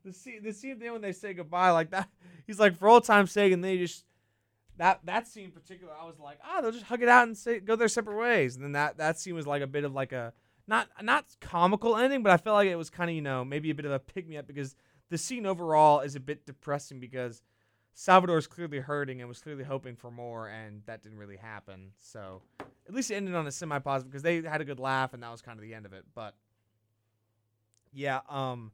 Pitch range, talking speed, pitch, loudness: 120-185 Hz, 255 wpm, 145 Hz, -28 LUFS